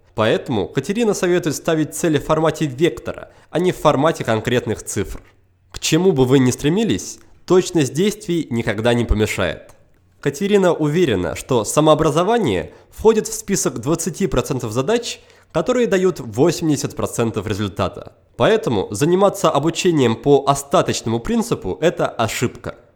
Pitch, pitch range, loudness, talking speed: 150 Hz, 115-180 Hz, -18 LUFS, 120 wpm